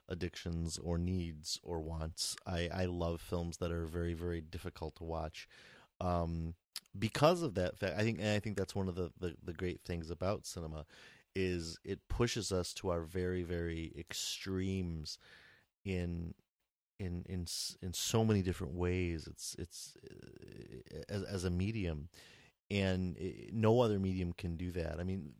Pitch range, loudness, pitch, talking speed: 85-95 Hz, -38 LUFS, 90 Hz, 165 wpm